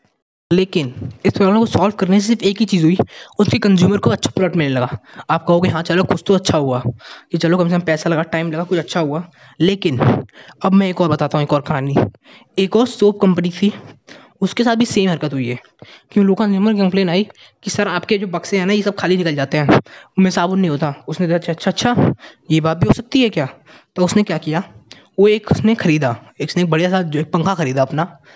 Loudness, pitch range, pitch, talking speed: -16 LUFS, 155-195 Hz, 180 Hz, 235 wpm